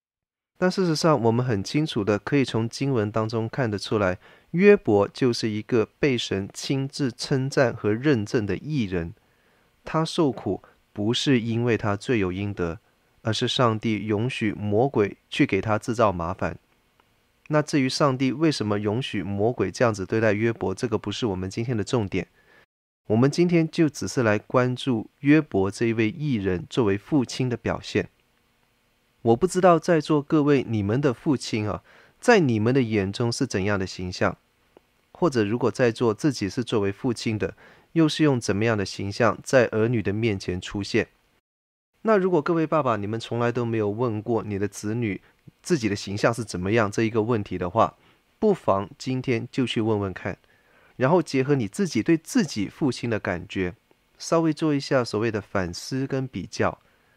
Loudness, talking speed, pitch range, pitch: -24 LUFS, 260 characters per minute, 100-135 Hz, 115 Hz